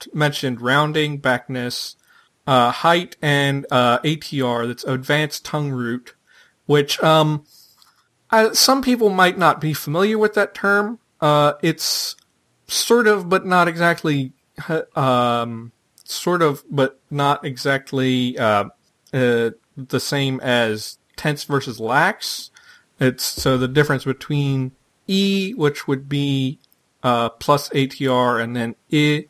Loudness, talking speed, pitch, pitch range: -19 LUFS, 125 wpm, 145 Hz, 130-155 Hz